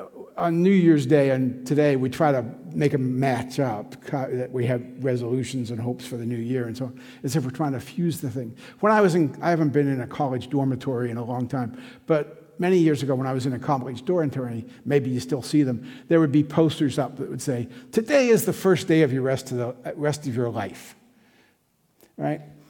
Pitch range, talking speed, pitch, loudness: 125-155 Hz, 235 wpm, 135 Hz, -24 LUFS